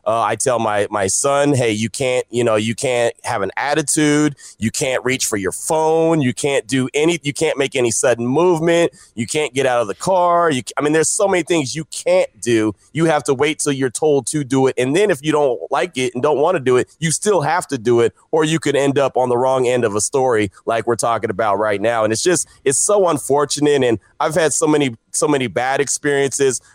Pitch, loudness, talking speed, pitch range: 140 Hz, -17 LUFS, 250 wpm, 120-155 Hz